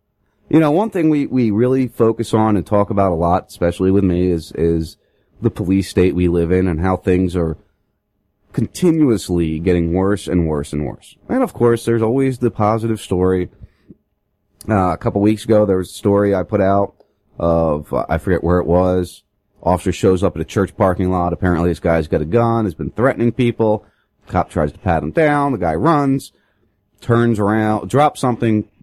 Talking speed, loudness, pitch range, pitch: 195 wpm, -17 LUFS, 90-115 Hz, 100 Hz